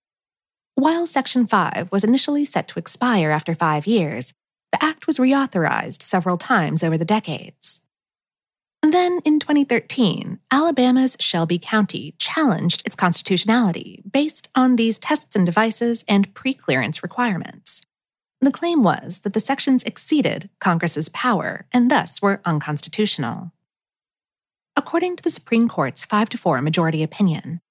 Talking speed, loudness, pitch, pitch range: 130 wpm, -20 LUFS, 215 Hz, 170-260 Hz